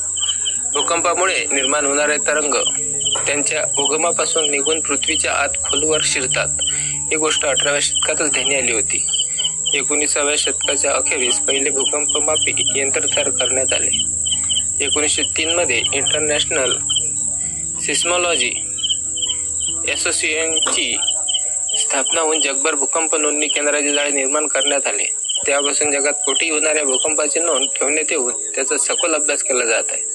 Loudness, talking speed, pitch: -16 LUFS, 105 wpm, 145 Hz